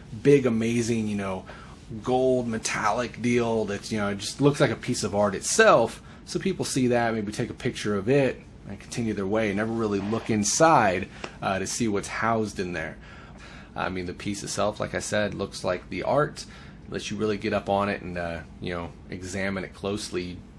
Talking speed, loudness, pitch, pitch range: 205 wpm, -26 LUFS, 105 Hz, 100-115 Hz